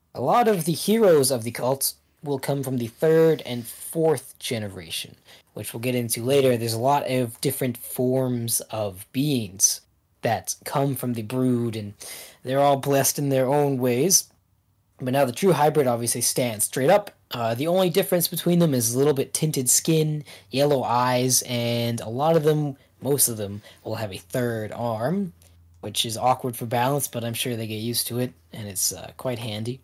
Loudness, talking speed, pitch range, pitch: -23 LUFS, 195 wpm, 115-140 Hz, 125 Hz